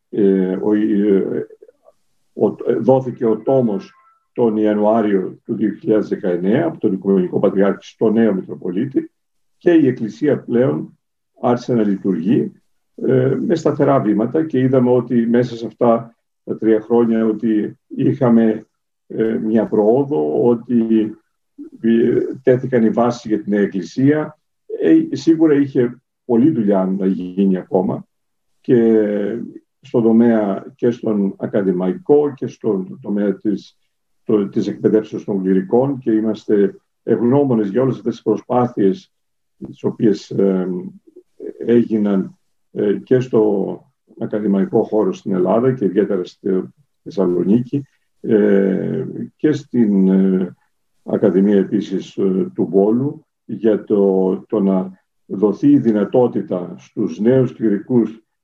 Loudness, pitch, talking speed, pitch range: -17 LUFS, 115 Hz, 115 wpm, 100-130 Hz